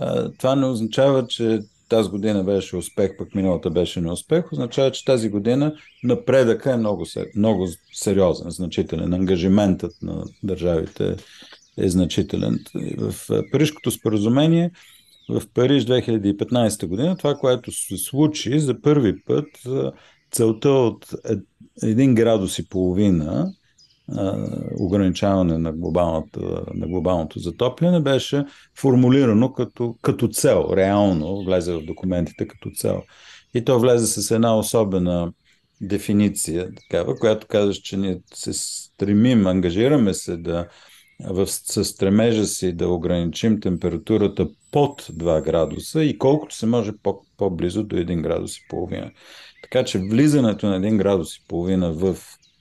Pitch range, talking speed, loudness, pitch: 90-125 Hz, 125 wpm, -21 LUFS, 105 Hz